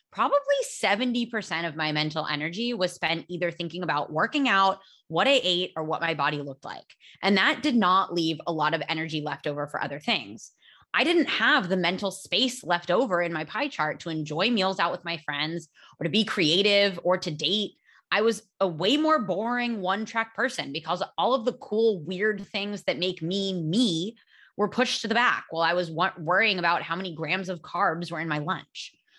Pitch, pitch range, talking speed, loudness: 185 Hz, 165-220 Hz, 210 wpm, -26 LUFS